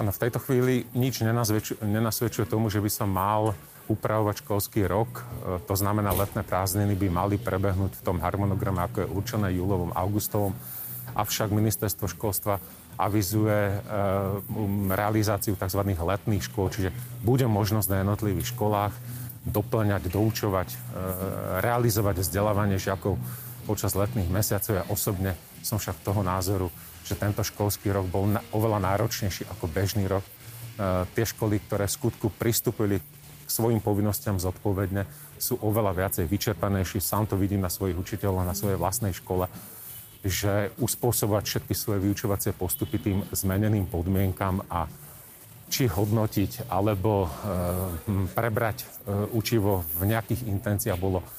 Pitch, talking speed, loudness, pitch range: 105 Hz, 135 wpm, -27 LUFS, 95-110 Hz